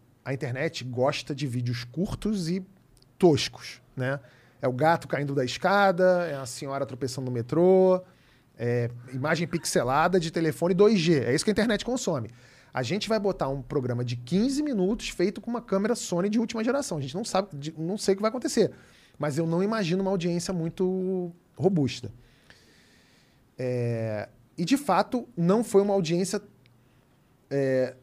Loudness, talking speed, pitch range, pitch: -27 LUFS, 165 wpm, 130-190 Hz, 165 Hz